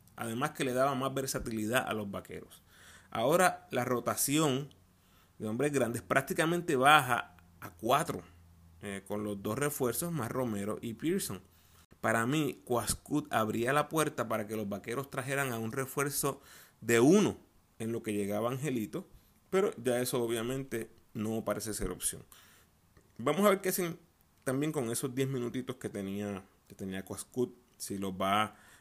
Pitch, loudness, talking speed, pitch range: 115 Hz, -32 LUFS, 155 wpm, 100-135 Hz